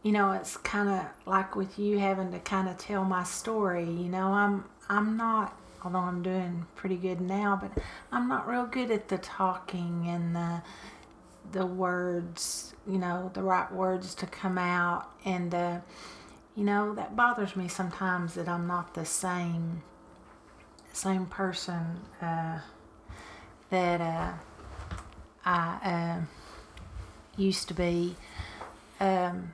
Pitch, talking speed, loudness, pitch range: 180 Hz, 140 wpm, -31 LUFS, 170-195 Hz